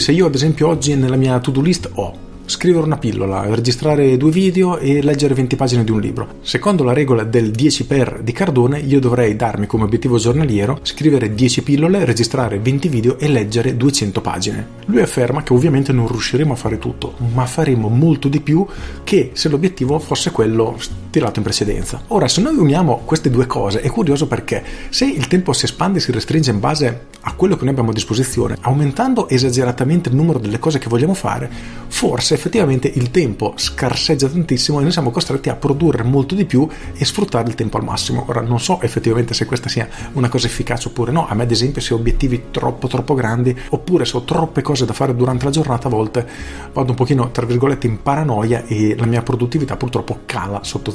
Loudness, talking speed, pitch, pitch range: -16 LUFS, 205 wpm, 130 Hz, 115-145 Hz